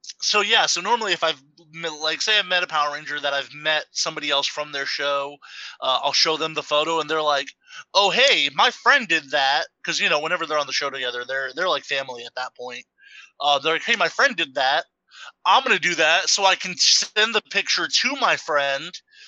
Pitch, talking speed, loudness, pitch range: 160 Hz, 230 wpm, -20 LUFS, 140-190 Hz